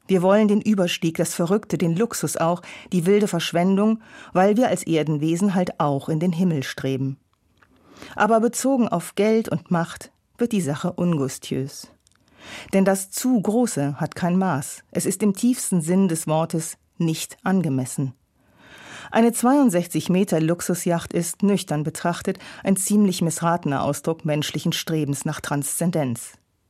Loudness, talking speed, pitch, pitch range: -22 LUFS, 140 wpm, 175 Hz, 155-195 Hz